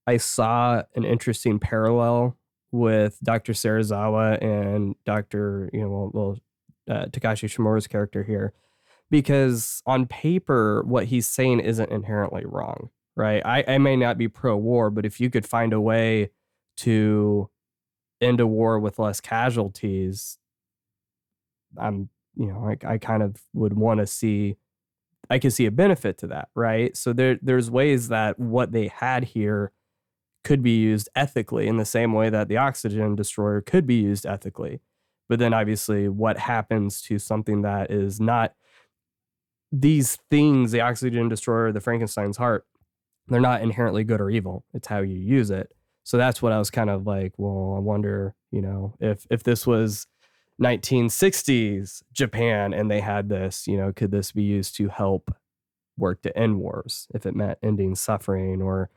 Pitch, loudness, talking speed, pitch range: 110 Hz, -23 LUFS, 165 wpm, 100-120 Hz